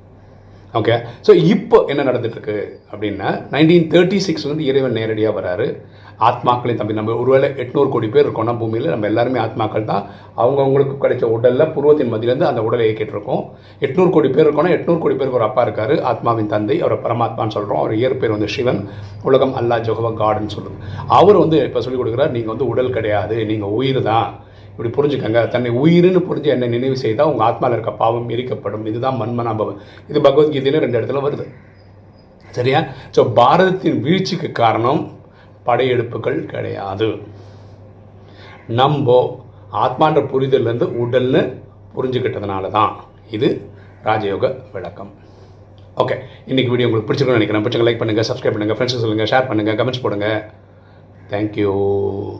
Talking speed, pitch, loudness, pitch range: 135 wpm, 115 Hz, -17 LUFS, 105-135 Hz